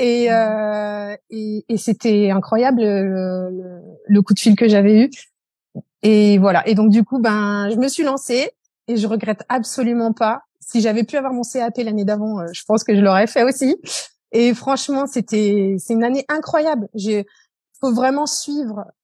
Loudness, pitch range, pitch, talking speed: -17 LUFS, 210-250 Hz, 220 Hz, 180 wpm